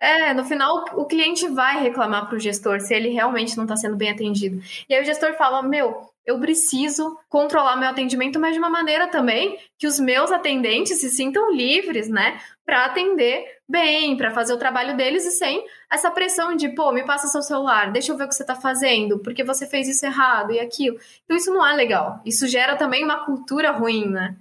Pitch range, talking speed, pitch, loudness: 245-315 Hz, 215 wpm, 275 Hz, -20 LUFS